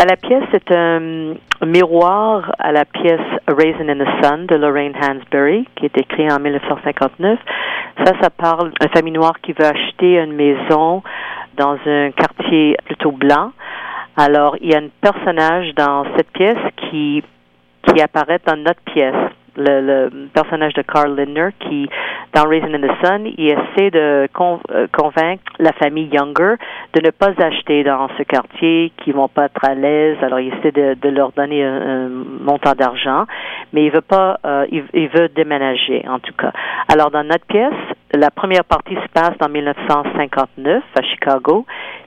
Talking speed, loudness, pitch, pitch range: 170 wpm, -15 LUFS, 150 Hz, 145-165 Hz